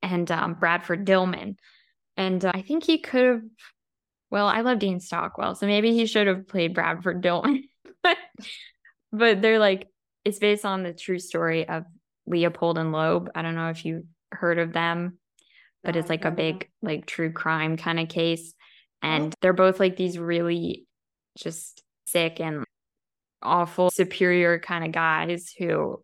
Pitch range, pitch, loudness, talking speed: 165-205 Hz, 180 Hz, -24 LUFS, 165 wpm